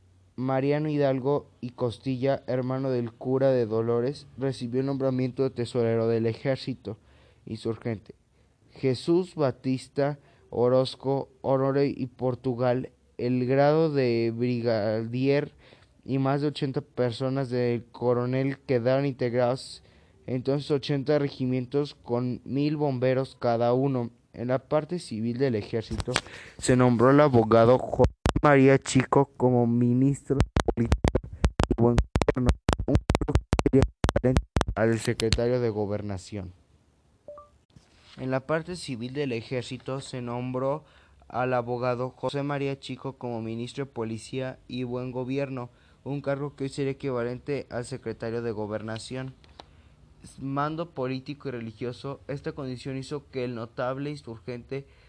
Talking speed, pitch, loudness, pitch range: 120 wpm, 130 Hz, -27 LUFS, 120-135 Hz